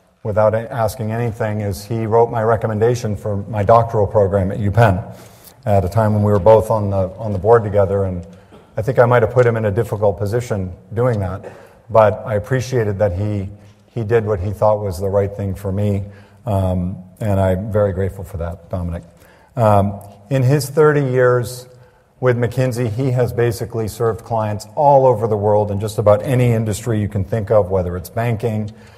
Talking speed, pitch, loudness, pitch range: 195 wpm, 105 Hz, -17 LUFS, 100-115 Hz